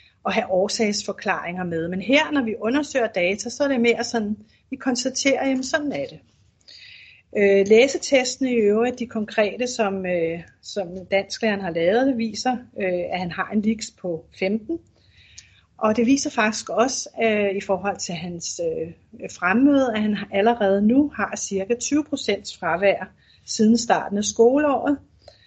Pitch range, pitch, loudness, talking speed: 195-260 Hz, 220 Hz, -22 LUFS, 150 wpm